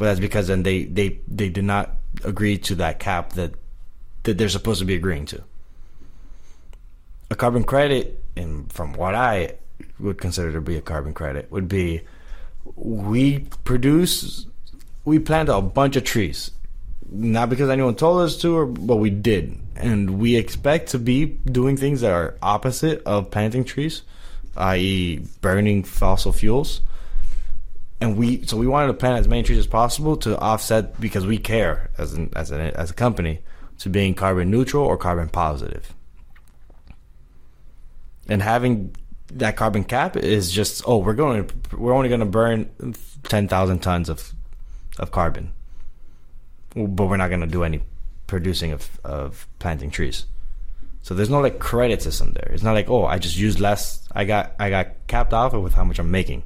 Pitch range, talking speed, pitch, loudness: 80-115 Hz, 170 wpm, 100 Hz, -22 LUFS